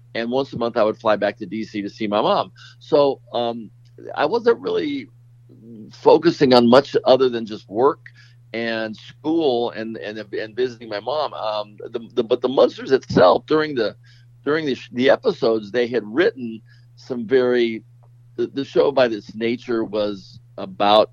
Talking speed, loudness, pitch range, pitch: 175 wpm, -20 LUFS, 110-125 Hz, 120 Hz